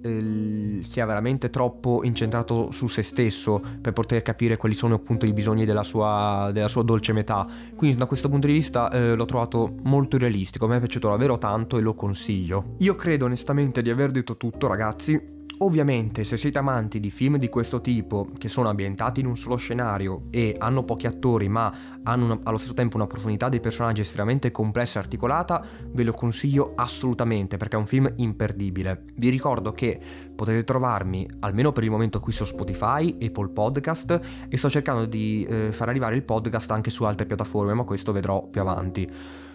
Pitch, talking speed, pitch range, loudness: 115 Hz, 185 wpm, 105-125 Hz, -25 LUFS